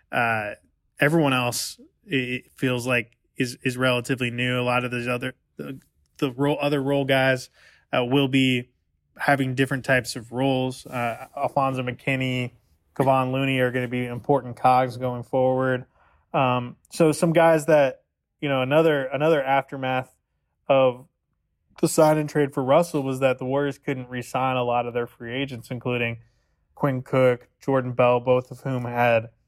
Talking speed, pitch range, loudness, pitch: 160 wpm, 125-135 Hz, -23 LUFS, 130 Hz